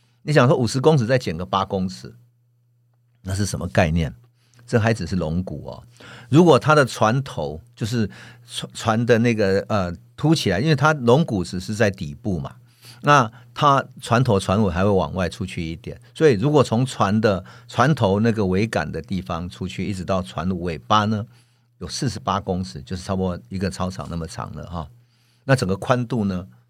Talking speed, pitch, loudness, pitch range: 270 characters per minute, 115 Hz, -21 LUFS, 95-120 Hz